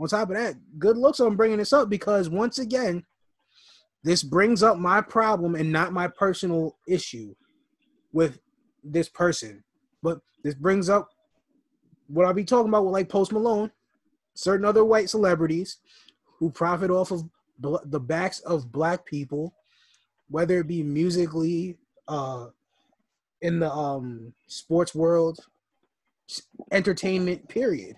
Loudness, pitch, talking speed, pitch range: -24 LUFS, 185 Hz, 135 wpm, 165-220 Hz